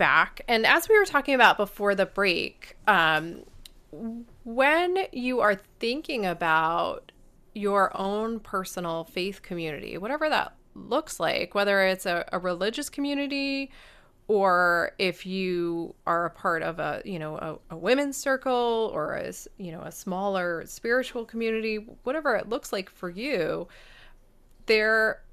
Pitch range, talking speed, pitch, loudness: 180-250 Hz, 140 wpm, 205 Hz, -26 LUFS